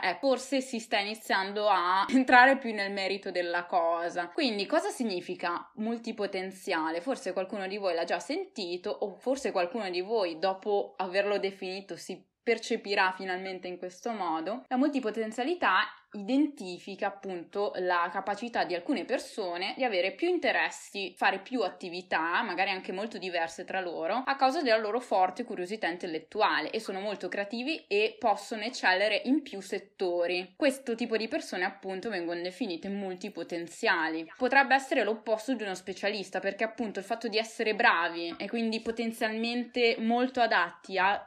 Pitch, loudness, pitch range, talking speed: 205 Hz, -30 LUFS, 185-235 Hz, 150 wpm